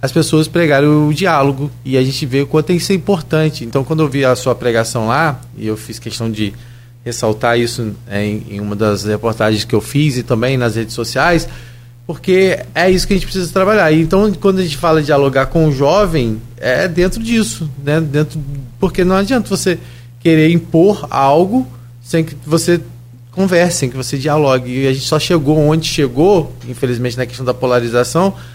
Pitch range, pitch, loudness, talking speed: 120-165 Hz, 140 Hz, -14 LUFS, 195 wpm